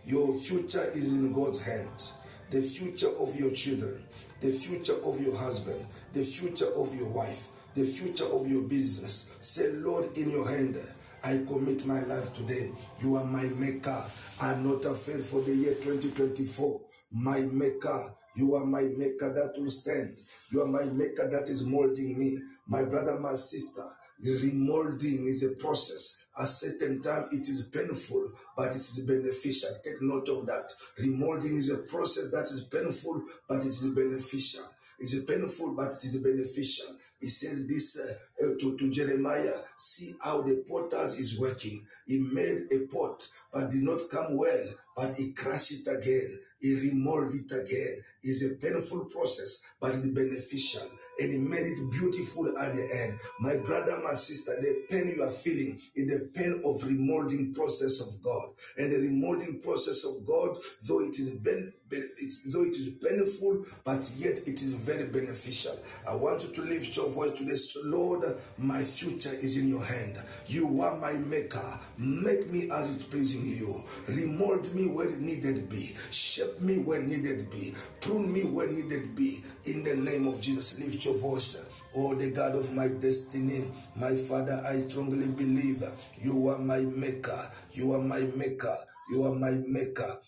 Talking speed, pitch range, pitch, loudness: 175 wpm, 130-145 Hz, 135 Hz, -32 LUFS